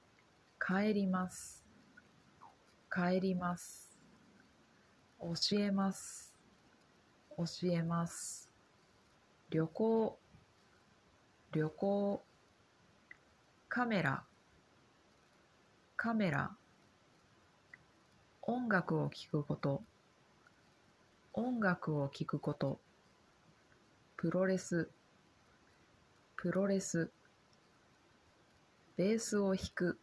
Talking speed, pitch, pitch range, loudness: 110 characters per minute, 180 Hz, 165-200 Hz, -38 LUFS